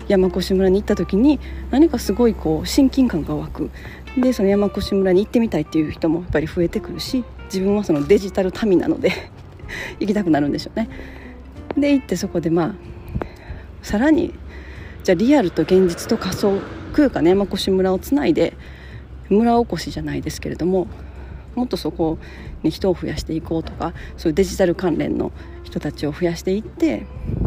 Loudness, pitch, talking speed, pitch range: -20 LUFS, 195 Hz, 360 characters per minute, 175-240 Hz